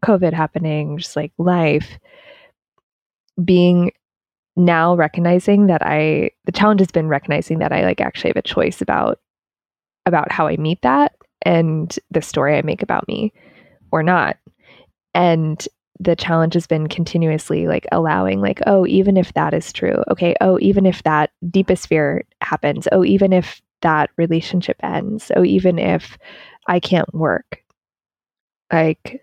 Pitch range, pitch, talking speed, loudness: 155-185 Hz, 170 Hz, 150 wpm, -17 LUFS